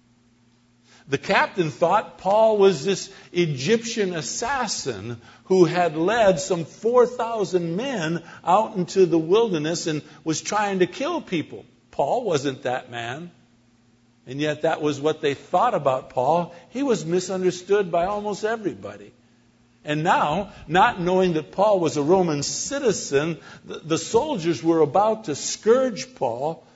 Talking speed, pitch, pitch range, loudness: 135 wpm, 170 Hz, 145-195 Hz, -22 LUFS